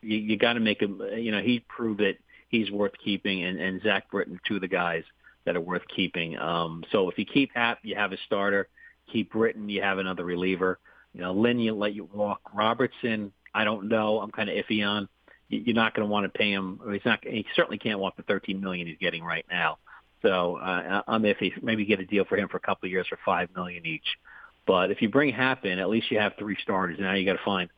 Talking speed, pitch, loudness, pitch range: 255 wpm, 105 Hz, -27 LUFS, 95-110 Hz